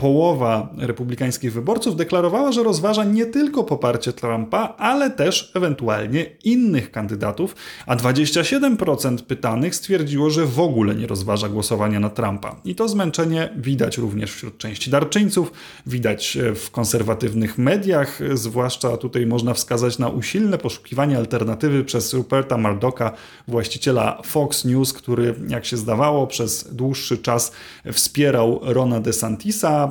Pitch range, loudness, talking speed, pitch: 115-160 Hz, -20 LUFS, 130 wpm, 125 Hz